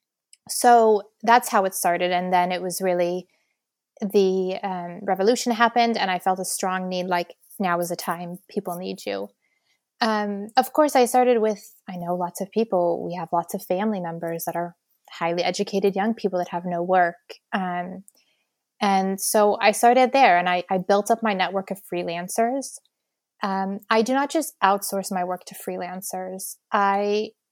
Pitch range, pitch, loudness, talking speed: 180-215 Hz, 195 Hz, -23 LUFS, 175 wpm